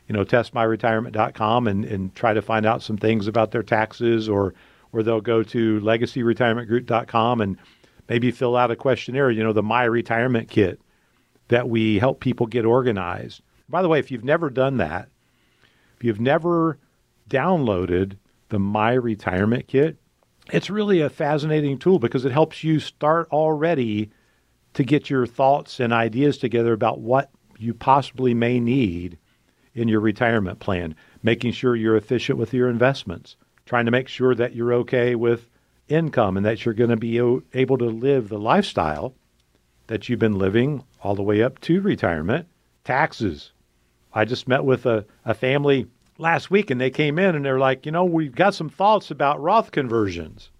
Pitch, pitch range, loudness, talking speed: 120 Hz, 110-135 Hz, -21 LUFS, 170 wpm